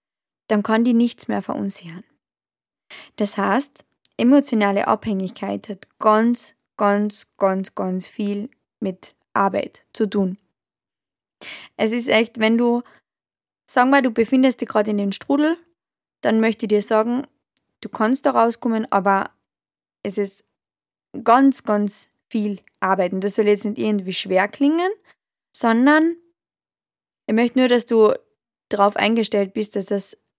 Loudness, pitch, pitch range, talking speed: -20 LUFS, 215 Hz, 200-240 Hz, 140 wpm